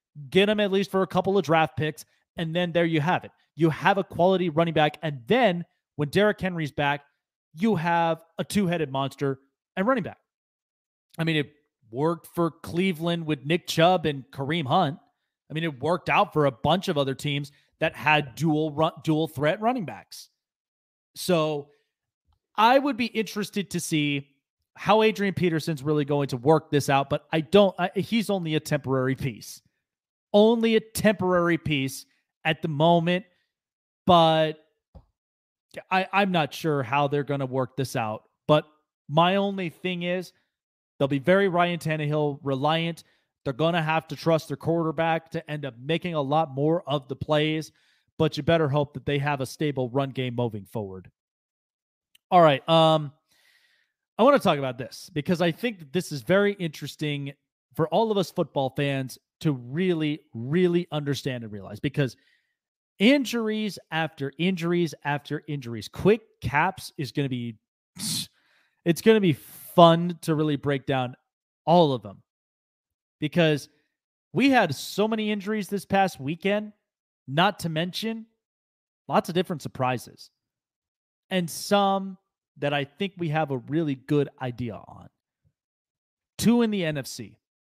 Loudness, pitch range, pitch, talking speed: -25 LUFS, 145-180 Hz, 160 Hz, 165 wpm